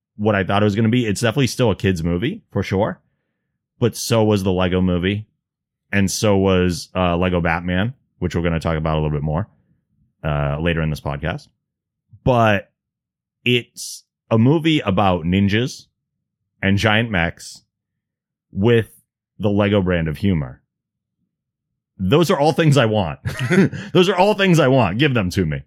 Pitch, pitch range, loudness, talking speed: 100 Hz, 90-120 Hz, -18 LUFS, 175 wpm